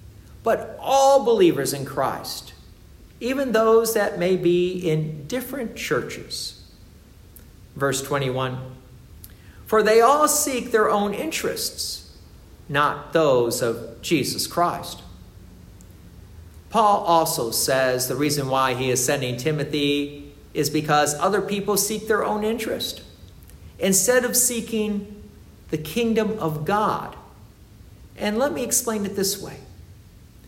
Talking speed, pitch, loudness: 115 wpm, 155 Hz, -22 LUFS